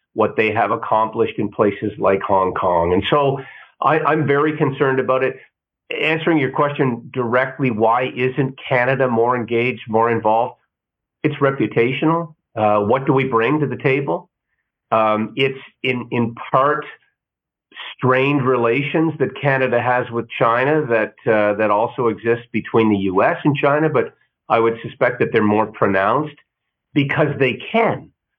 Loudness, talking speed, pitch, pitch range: -18 LUFS, 150 wpm, 130 Hz, 115-145 Hz